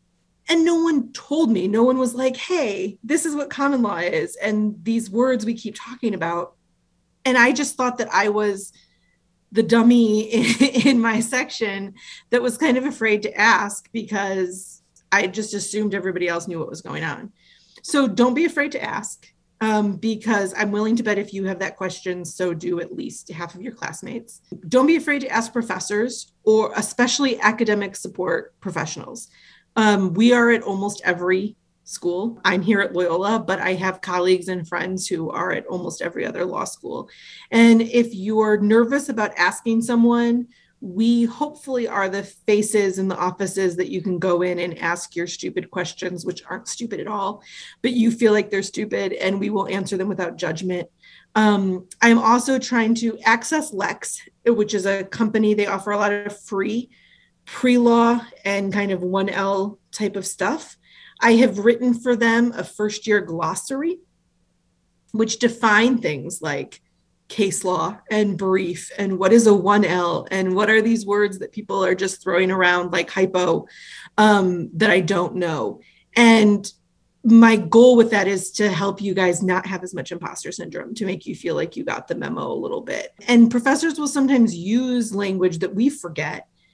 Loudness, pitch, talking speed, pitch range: -20 LUFS, 210 Hz, 180 wpm, 190-235 Hz